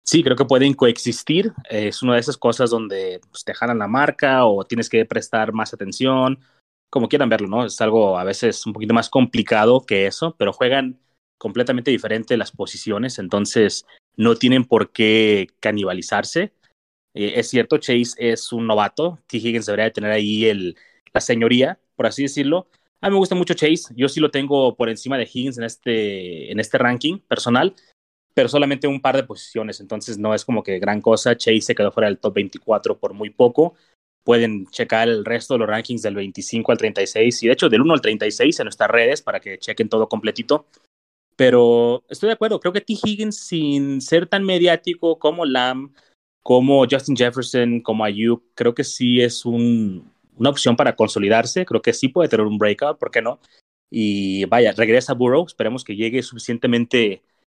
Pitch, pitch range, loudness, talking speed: 120 Hz, 110-140 Hz, -19 LUFS, 190 wpm